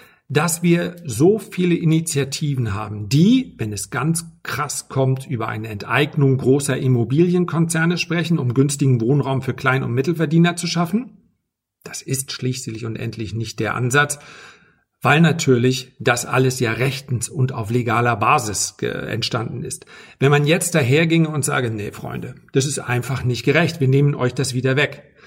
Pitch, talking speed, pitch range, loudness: 135 Hz, 160 wpm, 125-160 Hz, -19 LUFS